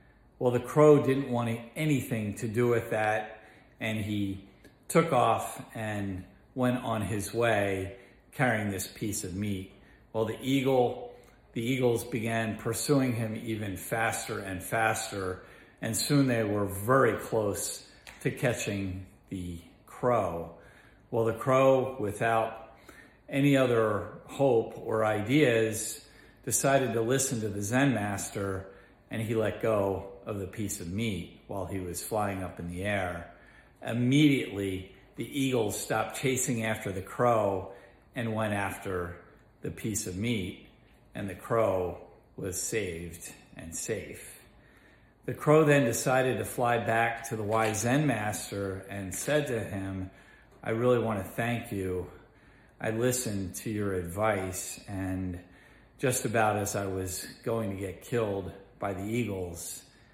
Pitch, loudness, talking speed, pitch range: 110 Hz, -30 LUFS, 140 wpm, 95-120 Hz